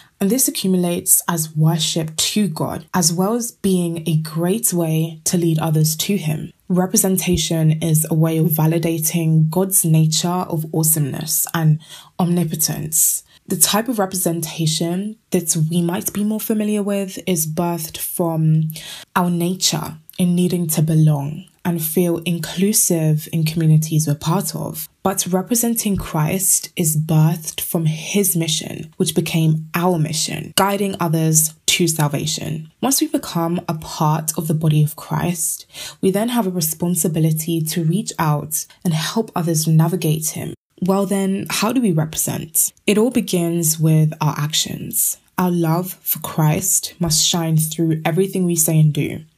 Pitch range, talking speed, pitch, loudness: 160-185 Hz, 150 wpm, 170 Hz, -18 LUFS